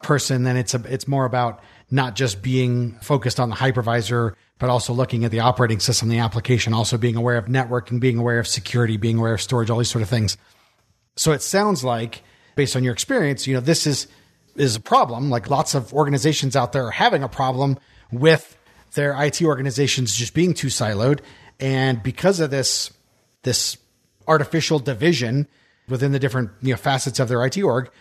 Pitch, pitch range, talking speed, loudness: 130 Hz, 120-140 Hz, 195 wpm, -20 LUFS